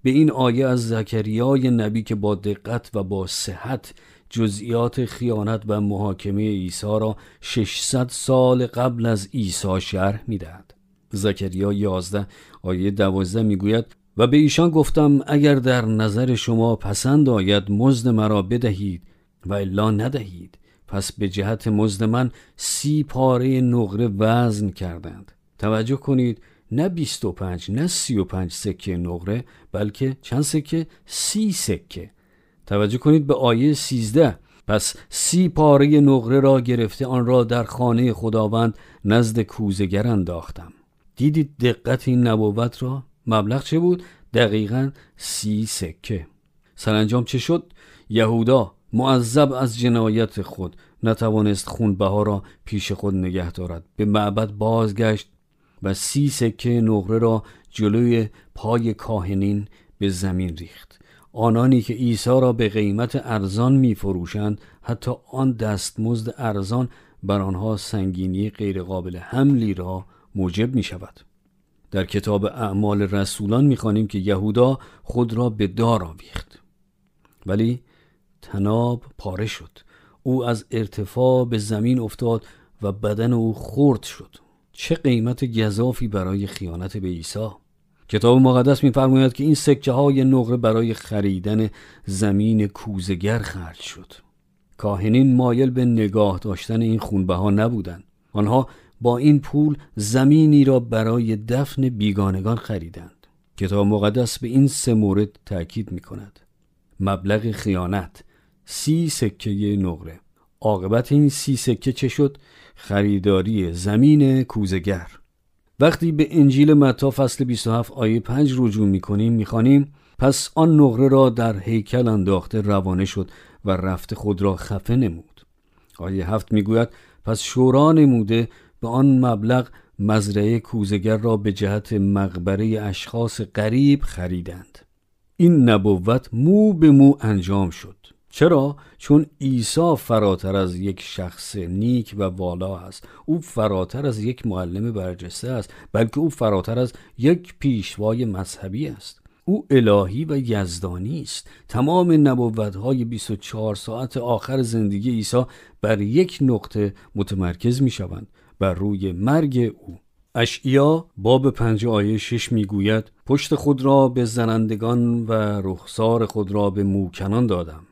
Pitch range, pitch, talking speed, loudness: 100-125 Hz, 110 Hz, 130 wpm, -20 LUFS